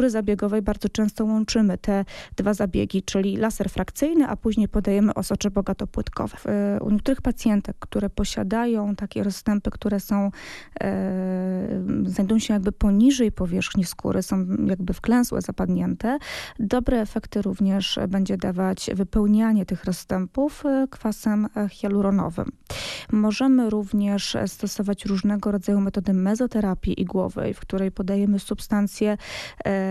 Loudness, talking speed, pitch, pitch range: -24 LUFS, 115 wpm, 205 Hz, 195-220 Hz